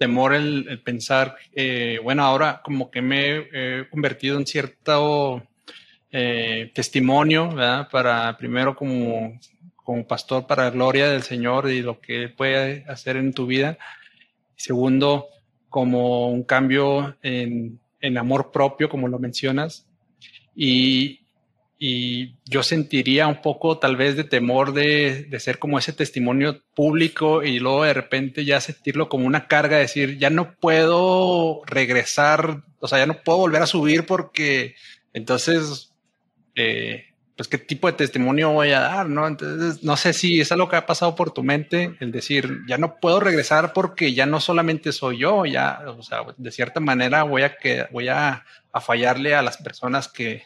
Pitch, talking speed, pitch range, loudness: 140 Hz, 165 wpm, 130-155 Hz, -21 LUFS